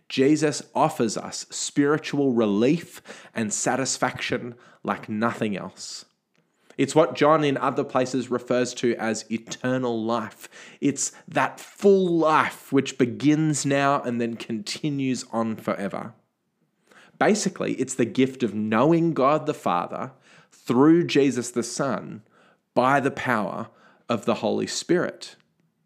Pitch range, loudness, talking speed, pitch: 120-150 Hz, -24 LUFS, 125 wpm, 130 Hz